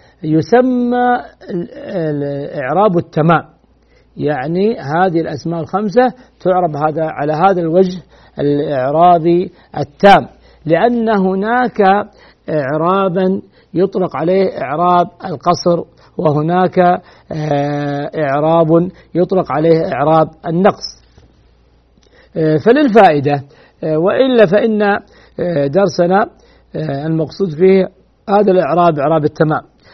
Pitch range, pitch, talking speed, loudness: 155-195 Hz, 175 Hz, 75 wpm, -14 LUFS